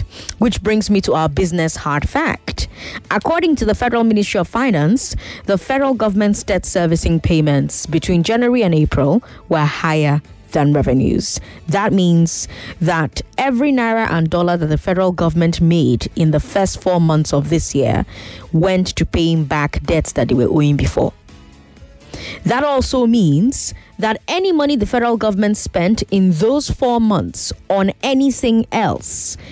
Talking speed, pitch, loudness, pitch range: 155 wpm, 180 Hz, -16 LUFS, 155-225 Hz